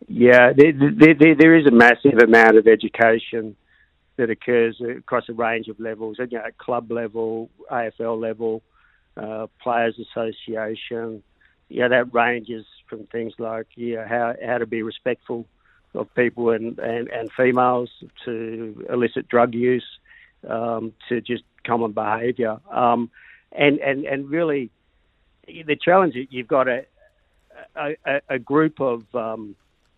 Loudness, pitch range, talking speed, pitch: -19 LUFS, 115-125 Hz, 140 wpm, 115 Hz